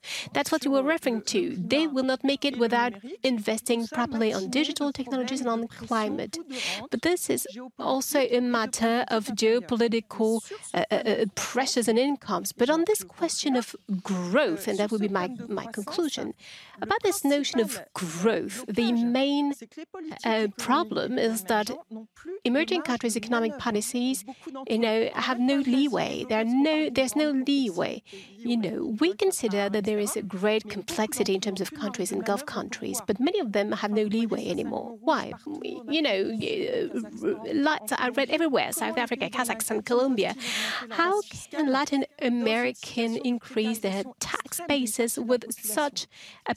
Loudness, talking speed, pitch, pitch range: -27 LUFS, 155 wpm, 245 Hz, 220-285 Hz